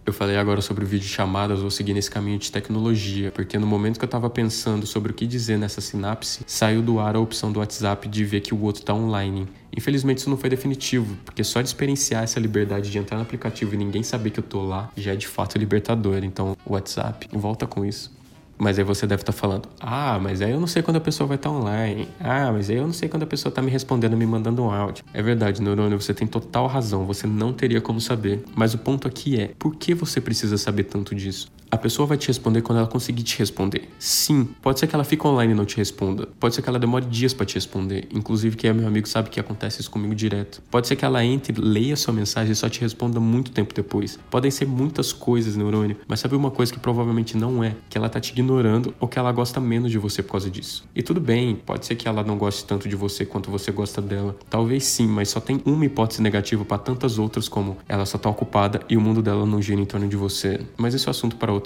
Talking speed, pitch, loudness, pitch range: 260 wpm, 110 Hz, -23 LUFS, 100-125 Hz